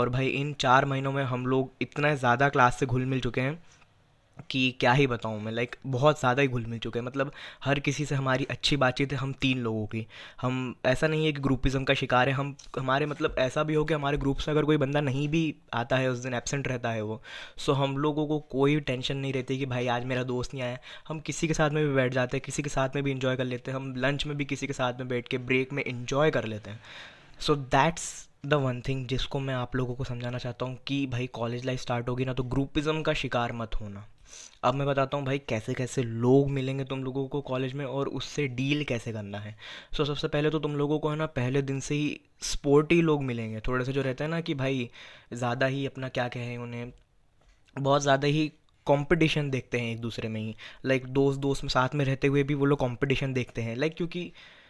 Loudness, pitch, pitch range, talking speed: -28 LUFS, 135 Hz, 125-145 Hz, 250 wpm